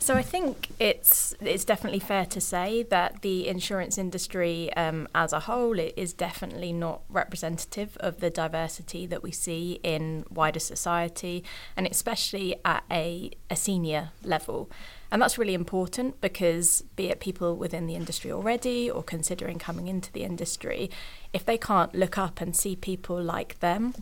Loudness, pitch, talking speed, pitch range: -28 LUFS, 180 Hz, 165 wpm, 170-195 Hz